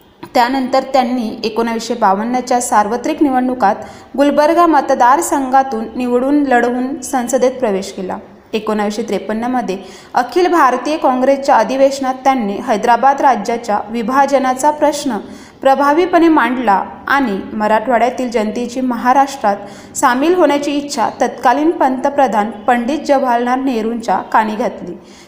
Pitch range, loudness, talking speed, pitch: 230-275 Hz, -14 LUFS, 95 wpm, 255 Hz